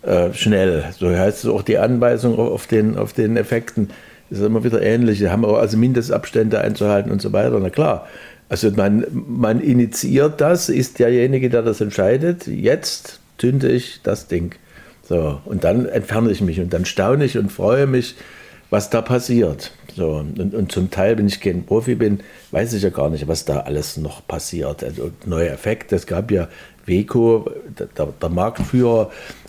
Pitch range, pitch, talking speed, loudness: 95-120 Hz, 110 Hz, 180 wpm, -18 LUFS